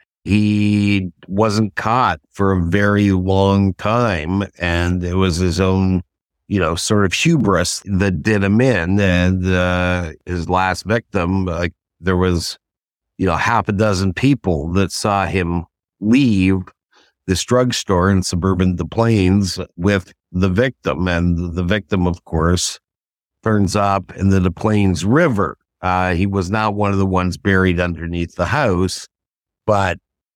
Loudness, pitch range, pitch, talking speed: -17 LUFS, 90-100 Hz, 95 Hz, 150 wpm